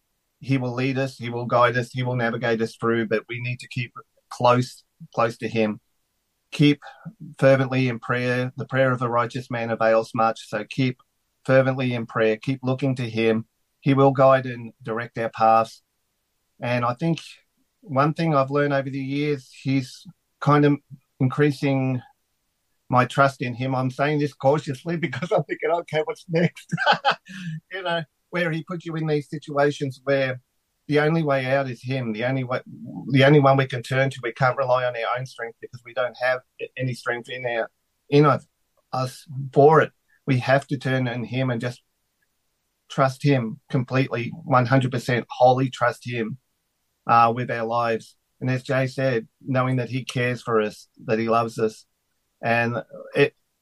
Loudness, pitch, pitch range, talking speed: -23 LUFS, 130 Hz, 120-140 Hz, 180 wpm